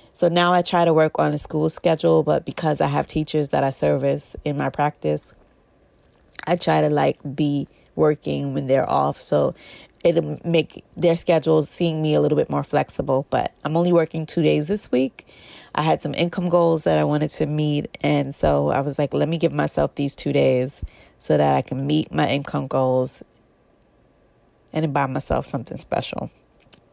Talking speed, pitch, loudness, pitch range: 190 wpm, 150 Hz, -21 LUFS, 130-160 Hz